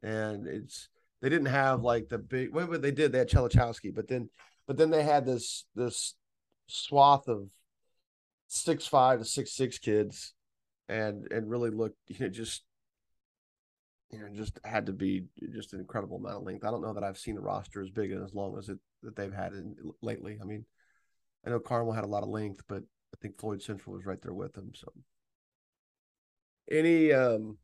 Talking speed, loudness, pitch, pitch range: 200 wpm, -31 LUFS, 110 Hz, 100-130 Hz